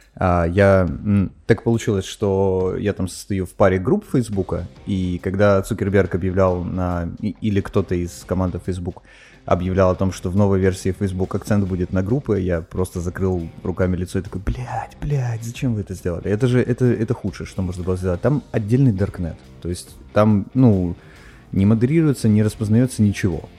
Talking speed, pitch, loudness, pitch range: 175 wpm, 95 Hz, -20 LUFS, 90-110 Hz